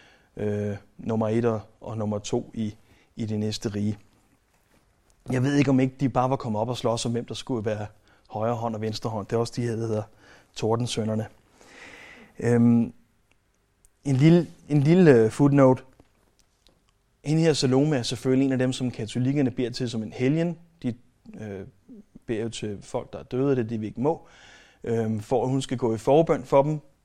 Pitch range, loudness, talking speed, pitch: 110-130 Hz, -25 LUFS, 195 wpm, 115 Hz